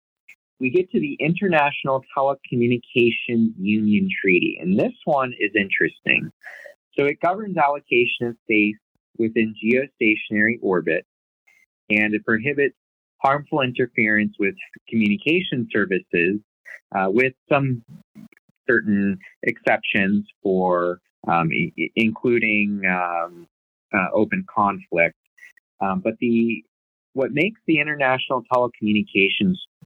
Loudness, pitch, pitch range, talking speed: -21 LUFS, 115 Hz, 105-145 Hz, 100 wpm